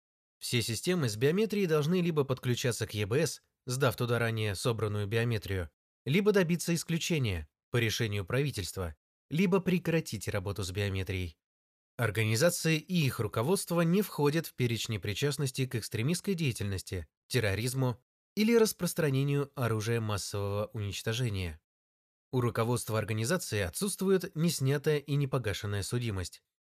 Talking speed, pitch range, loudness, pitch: 115 wpm, 105-155 Hz, -31 LUFS, 120 Hz